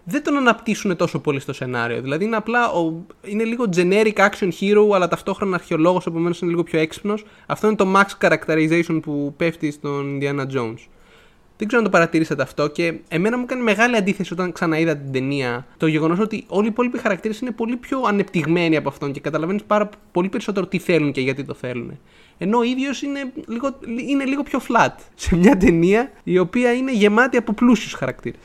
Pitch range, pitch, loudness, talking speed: 160-225 Hz, 185 Hz, -20 LUFS, 195 wpm